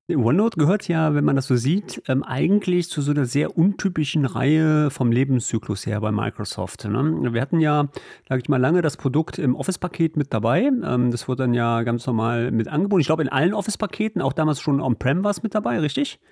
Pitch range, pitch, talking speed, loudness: 125-175 Hz, 145 Hz, 200 wpm, -22 LUFS